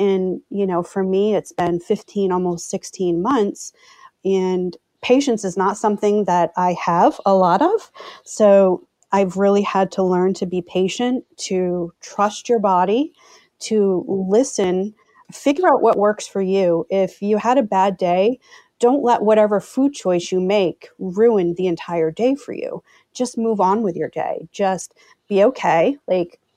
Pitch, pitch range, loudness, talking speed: 195 Hz, 185-225 Hz, -19 LUFS, 165 wpm